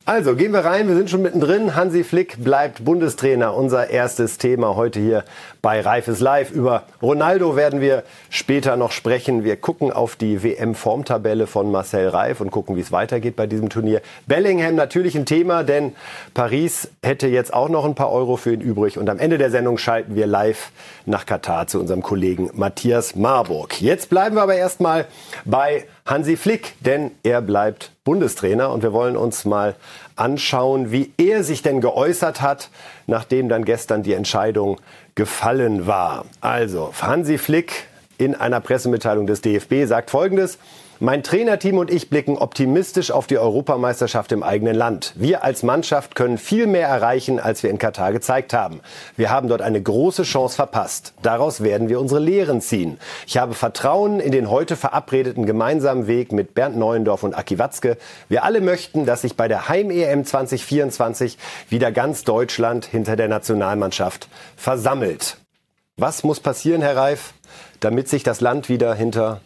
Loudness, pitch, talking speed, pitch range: -19 LUFS, 125 Hz, 170 wpm, 115-150 Hz